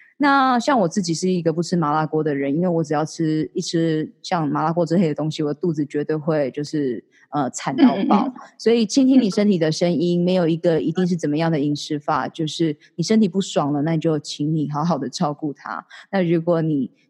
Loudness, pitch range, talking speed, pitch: -20 LUFS, 150-185 Hz, 320 characters per minute, 165 Hz